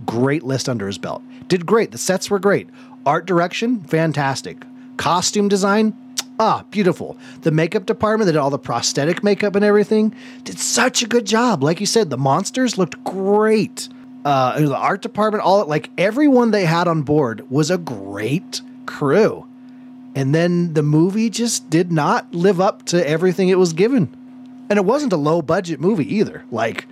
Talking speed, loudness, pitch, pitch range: 180 wpm, -18 LUFS, 200 Hz, 160-235 Hz